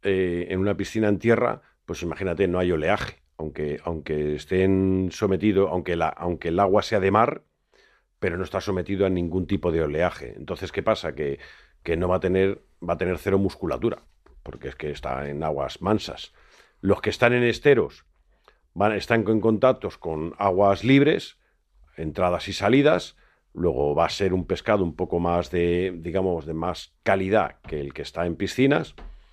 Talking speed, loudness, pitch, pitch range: 180 wpm, -24 LUFS, 95 Hz, 85-100 Hz